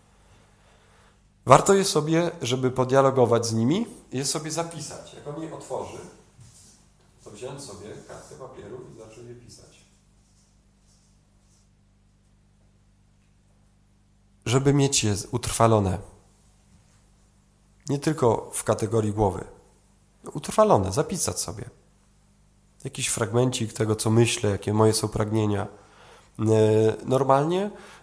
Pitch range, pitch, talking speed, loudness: 100-130 Hz, 110 Hz, 100 wpm, -23 LUFS